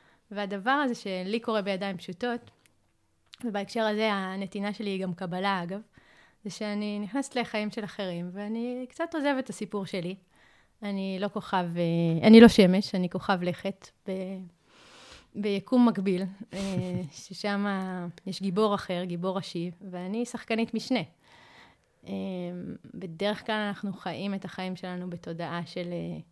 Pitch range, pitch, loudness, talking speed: 185-215 Hz, 195 Hz, -28 LUFS, 125 wpm